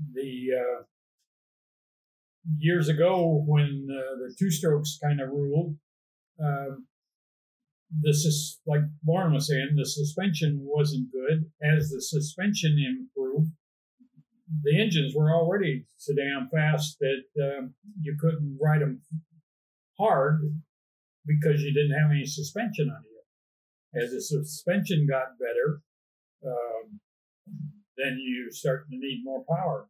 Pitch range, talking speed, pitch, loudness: 135-160 Hz, 125 wpm, 150 Hz, -27 LUFS